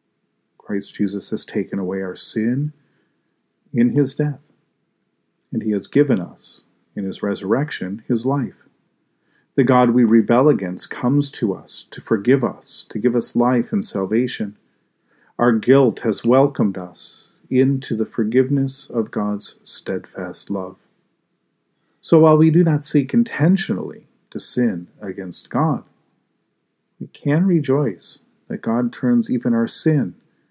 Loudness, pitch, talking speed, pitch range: -19 LUFS, 125 Hz, 135 wpm, 110-140 Hz